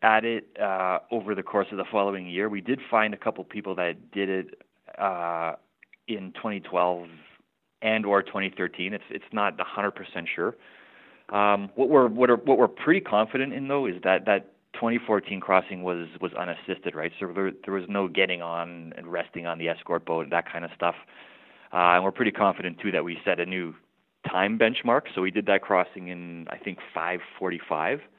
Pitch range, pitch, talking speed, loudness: 85-105 Hz, 95 Hz, 190 wpm, -26 LUFS